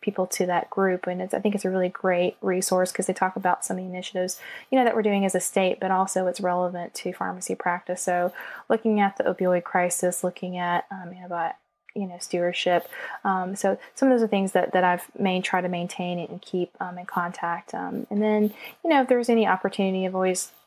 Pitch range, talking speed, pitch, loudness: 180-200 Hz, 235 wpm, 185 Hz, -25 LUFS